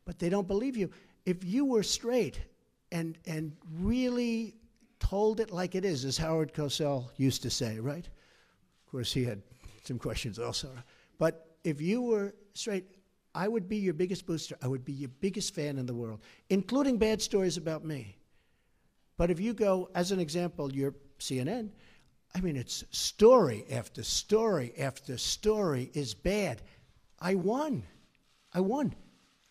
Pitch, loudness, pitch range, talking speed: 175 Hz, -32 LUFS, 135-205 Hz, 160 wpm